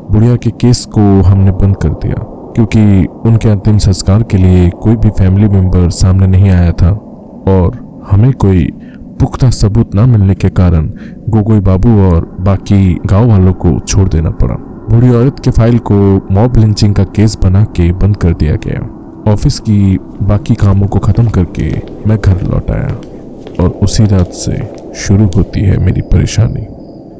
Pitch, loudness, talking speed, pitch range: 100 Hz, -10 LUFS, 170 wpm, 95-110 Hz